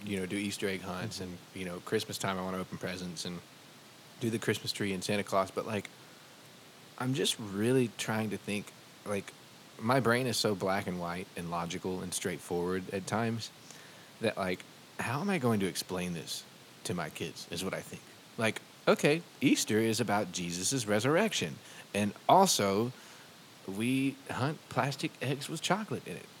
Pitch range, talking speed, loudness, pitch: 95-120 Hz, 180 wpm, -33 LUFS, 105 Hz